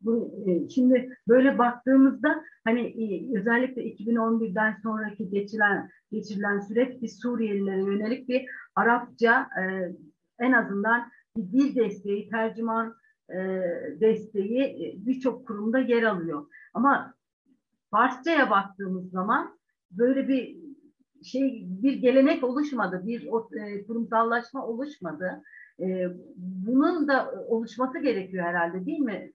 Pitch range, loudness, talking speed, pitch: 205-260 Hz, -26 LUFS, 95 wpm, 230 Hz